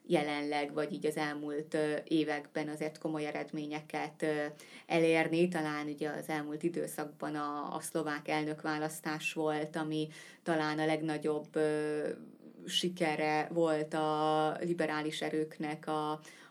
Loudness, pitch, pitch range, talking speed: -35 LUFS, 155 Hz, 150-160 Hz, 110 wpm